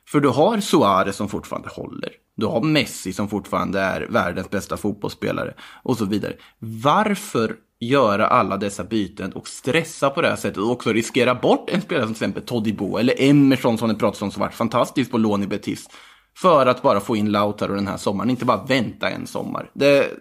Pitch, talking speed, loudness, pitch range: 110 Hz, 200 wpm, -21 LUFS, 100-140 Hz